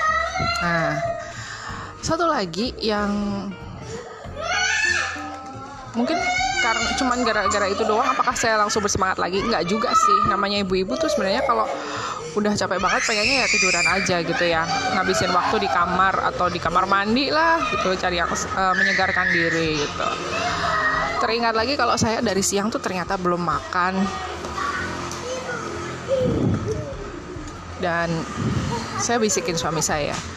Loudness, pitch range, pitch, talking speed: -21 LUFS, 185-250 Hz, 205 Hz, 125 wpm